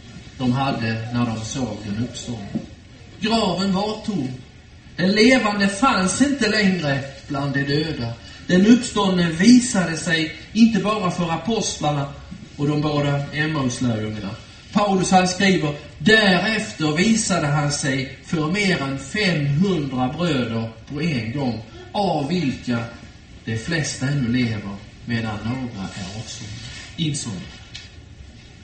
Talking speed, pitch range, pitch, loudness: 115 wpm, 120-185 Hz, 145 Hz, -20 LUFS